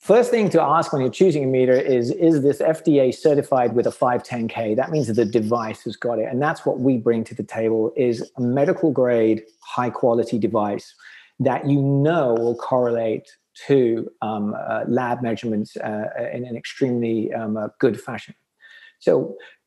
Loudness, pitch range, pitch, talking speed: -21 LUFS, 115-140 Hz, 120 Hz, 175 wpm